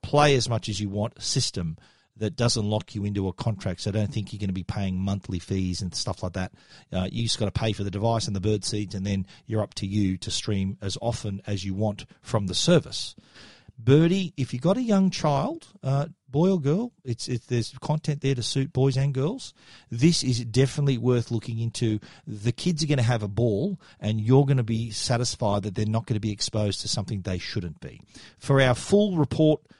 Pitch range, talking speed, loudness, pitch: 105-135 Hz, 230 wpm, -26 LUFS, 115 Hz